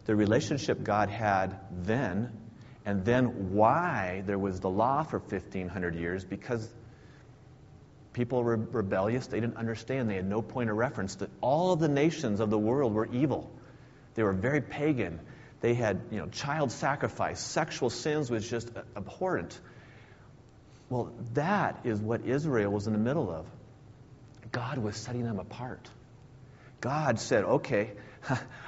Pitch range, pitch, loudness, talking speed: 105-130 Hz, 115 Hz, -31 LUFS, 155 wpm